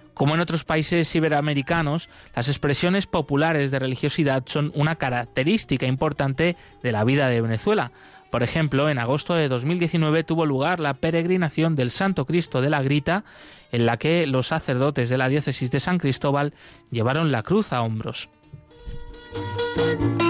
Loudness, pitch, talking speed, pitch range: -23 LUFS, 145 Hz, 150 wpm, 130-165 Hz